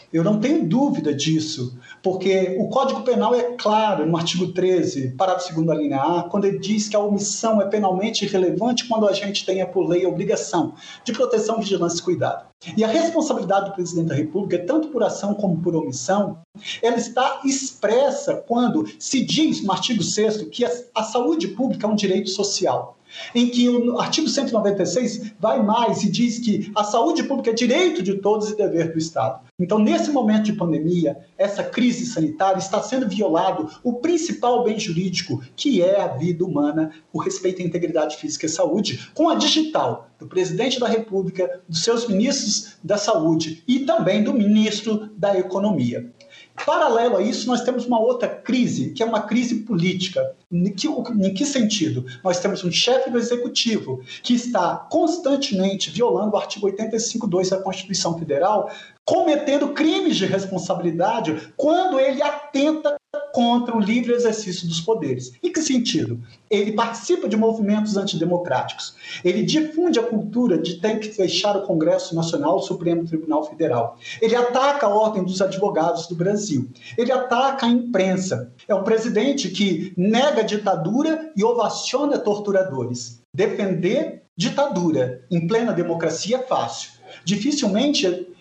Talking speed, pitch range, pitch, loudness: 160 wpm, 180-240 Hz, 205 Hz, -21 LUFS